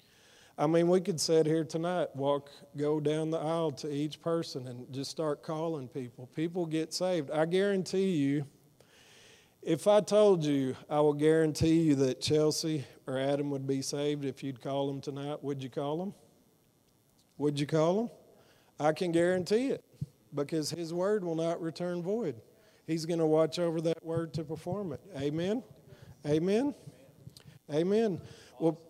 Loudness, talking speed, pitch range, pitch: -31 LUFS, 165 wpm, 145-170 Hz, 155 Hz